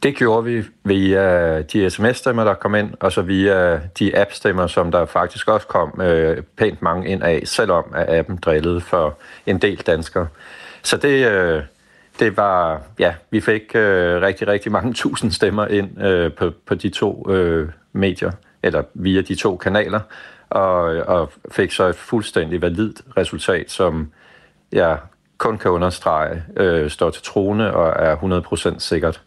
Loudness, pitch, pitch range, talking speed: -18 LUFS, 90 Hz, 85-100 Hz, 165 wpm